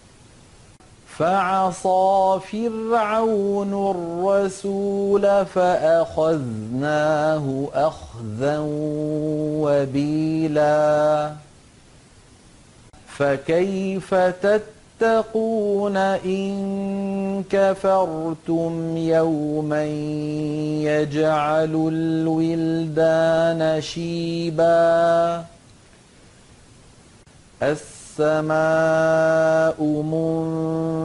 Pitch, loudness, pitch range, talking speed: 160 Hz, -21 LUFS, 150-190 Hz, 30 wpm